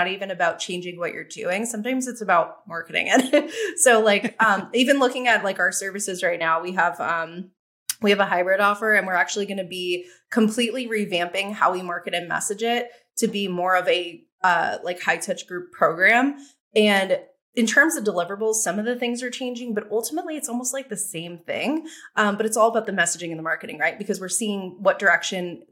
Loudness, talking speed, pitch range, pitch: -22 LUFS, 210 wpm, 180-240 Hz, 205 Hz